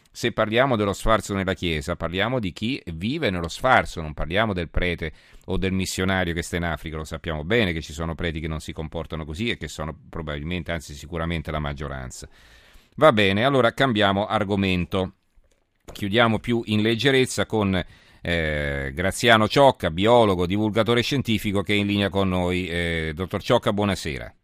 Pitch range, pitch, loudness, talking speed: 80-110 Hz, 95 Hz, -23 LUFS, 170 wpm